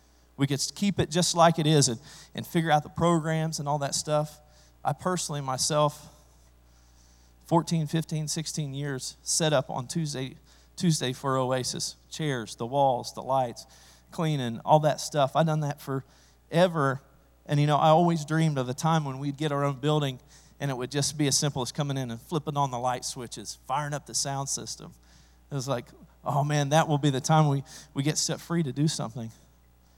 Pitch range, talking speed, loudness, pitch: 125-155 Hz, 200 wpm, -27 LUFS, 140 Hz